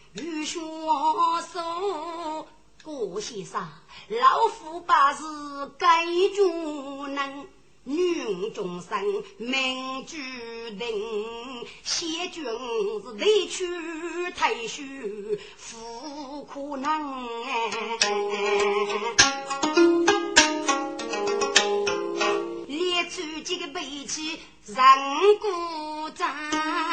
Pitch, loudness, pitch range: 315 Hz, -25 LUFS, 275-360 Hz